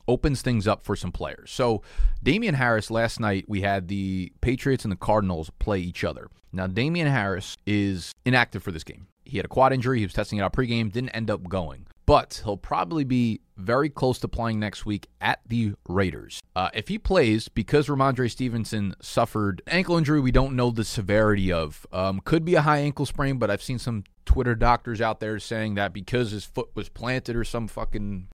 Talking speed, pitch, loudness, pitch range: 210 wpm, 110 Hz, -25 LUFS, 100-125 Hz